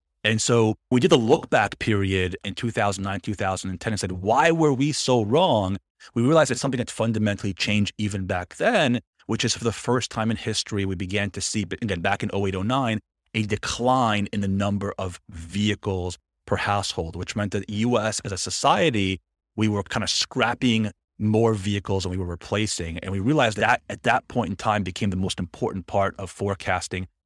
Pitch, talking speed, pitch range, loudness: 100 Hz, 195 wpm, 95-110 Hz, -24 LUFS